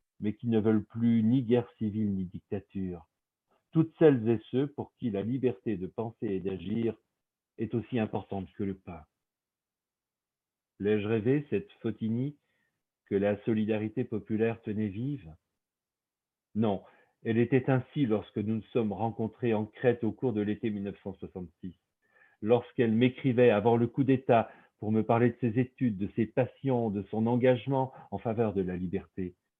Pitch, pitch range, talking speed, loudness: 110 Hz, 100-125 Hz, 155 wpm, -30 LUFS